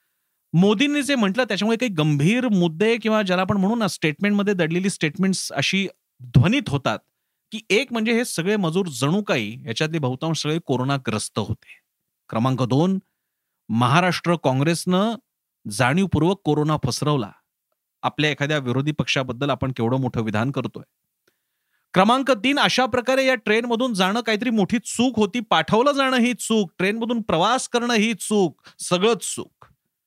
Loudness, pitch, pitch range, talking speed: -21 LUFS, 185 Hz, 150-225 Hz, 135 wpm